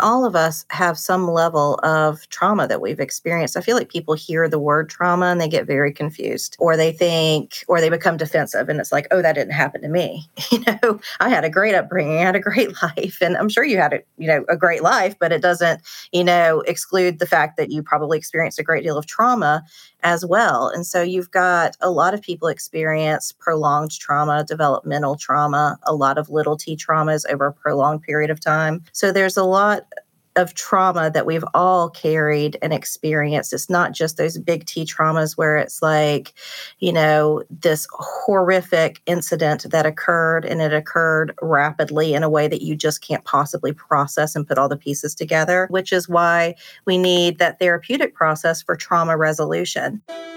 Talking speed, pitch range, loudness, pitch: 200 wpm, 155-180 Hz, -19 LUFS, 165 Hz